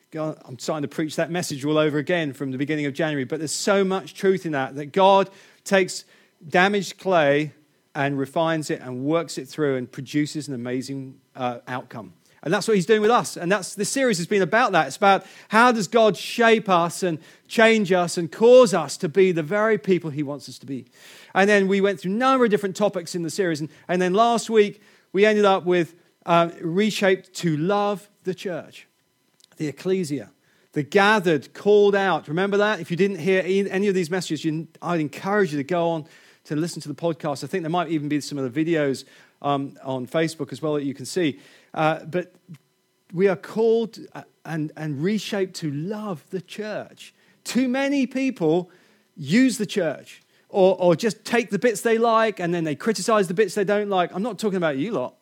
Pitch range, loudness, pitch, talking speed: 155-205 Hz, -22 LUFS, 180 Hz, 210 wpm